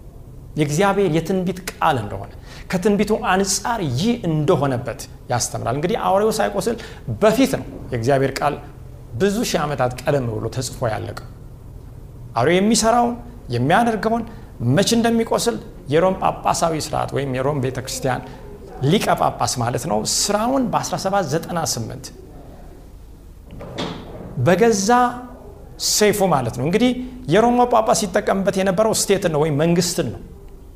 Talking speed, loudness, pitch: 105 wpm, -19 LUFS, 160 Hz